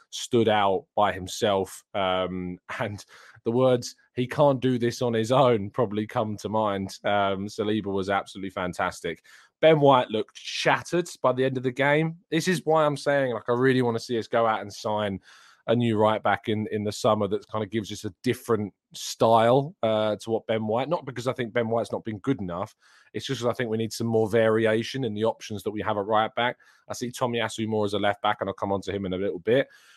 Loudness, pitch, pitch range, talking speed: -26 LUFS, 110 Hz, 105-125 Hz, 240 wpm